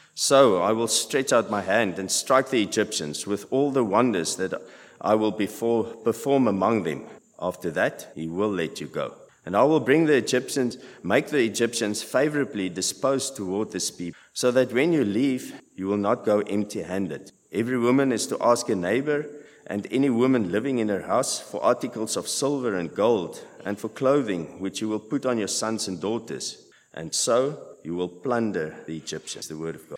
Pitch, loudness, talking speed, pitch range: 110 Hz, -25 LUFS, 190 wpm, 95-130 Hz